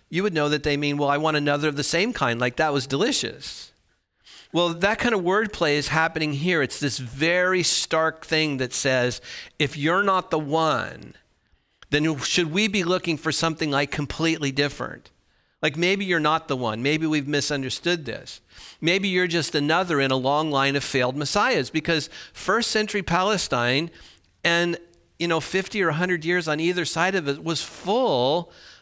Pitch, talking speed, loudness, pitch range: 160 Hz, 180 wpm, -23 LUFS, 145-175 Hz